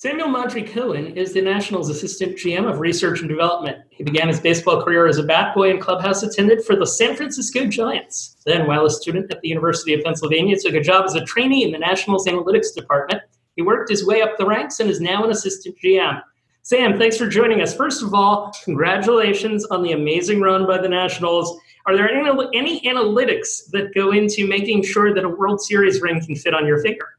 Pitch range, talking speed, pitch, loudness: 170-220 Hz, 215 wpm, 195 Hz, -18 LUFS